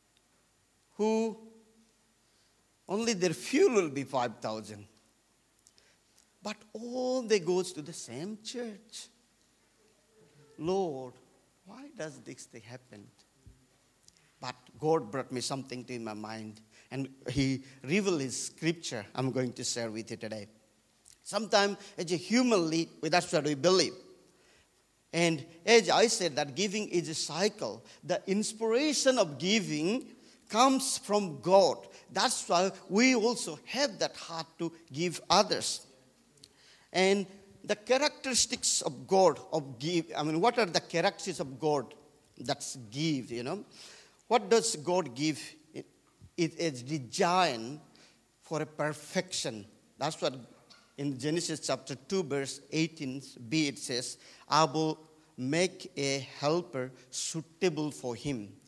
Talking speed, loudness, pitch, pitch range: 125 wpm, -31 LUFS, 160 Hz, 135-200 Hz